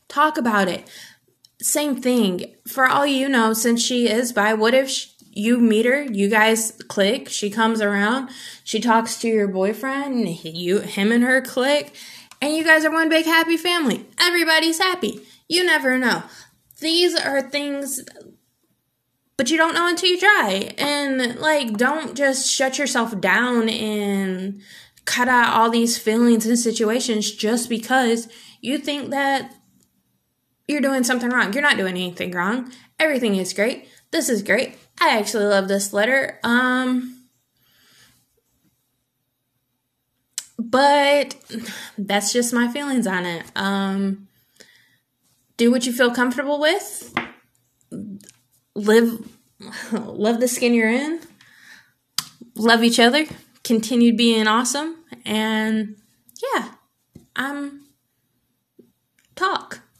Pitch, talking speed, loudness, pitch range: 235 Hz, 130 wpm, -19 LUFS, 215-275 Hz